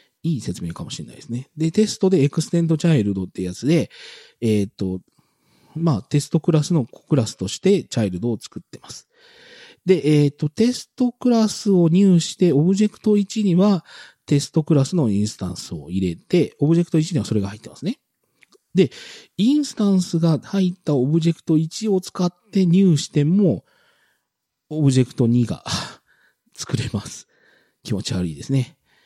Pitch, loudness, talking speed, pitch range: 160 Hz, -20 LUFS, 340 characters per minute, 125-190 Hz